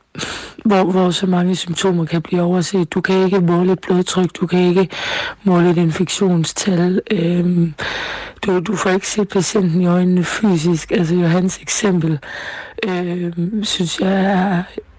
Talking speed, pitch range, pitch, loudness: 150 wpm, 175-190 Hz, 180 Hz, -17 LUFS